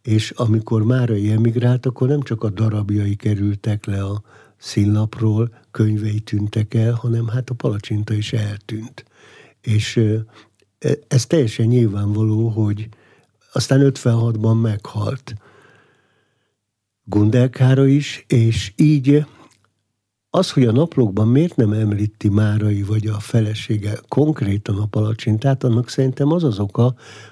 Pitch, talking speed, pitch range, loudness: 110 Hz, 115 wpm, 105-125 Hz, -18 LUFS